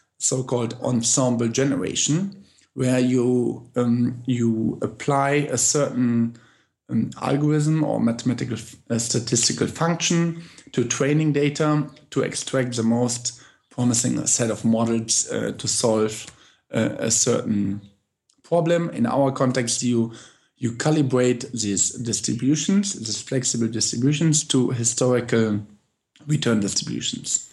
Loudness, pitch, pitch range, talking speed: -22 LUFS, 125 Hz, 115-145 Hz, 115 wpm